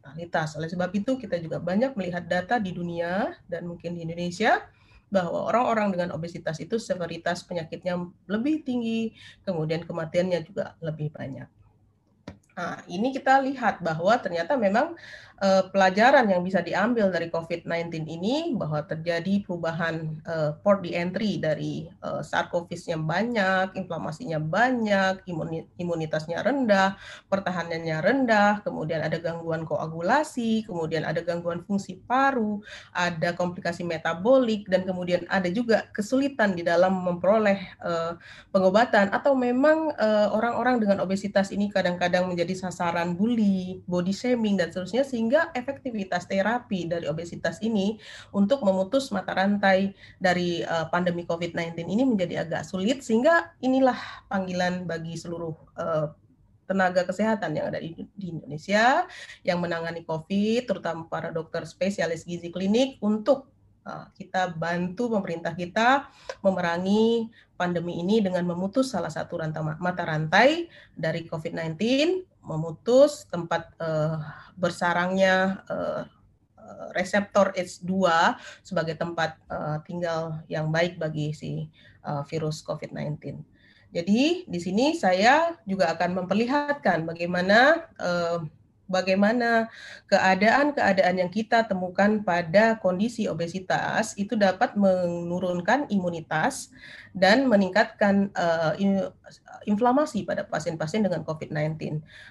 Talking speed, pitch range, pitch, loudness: 115 wpm, 170-215 Hz, 185 Hz, -25 LUFS